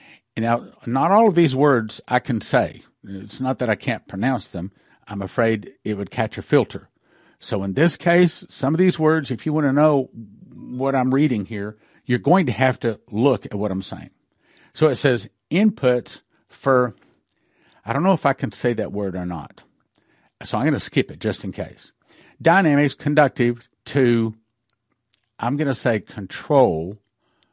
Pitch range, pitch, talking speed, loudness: 105-145 Hz, 125 Hz, 180 wpm, -20 LUFS